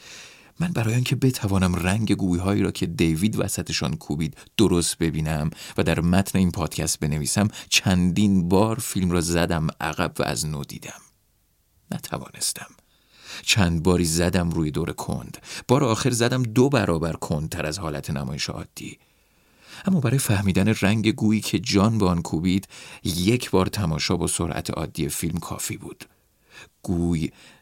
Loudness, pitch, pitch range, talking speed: -23 LUFS, 95 Hz, 85-110 Hz, 150 wpm